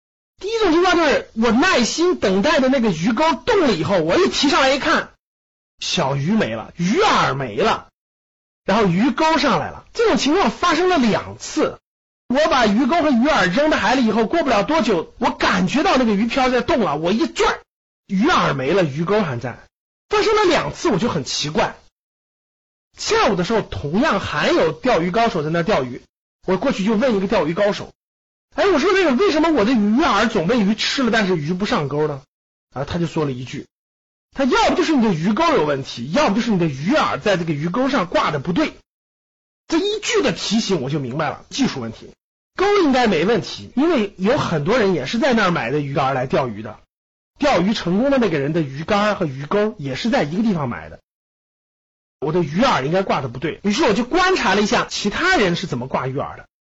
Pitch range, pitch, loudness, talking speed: 180-290 Hz, 225 Hz, -18 LUFS, 300 characters per minute